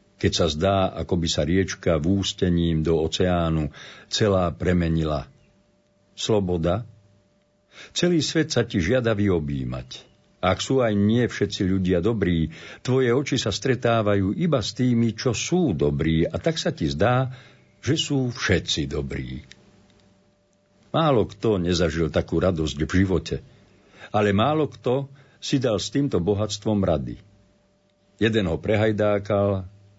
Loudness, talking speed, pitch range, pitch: -23 LUFS, 130 wpm, 85-120 Hz, 100 Hz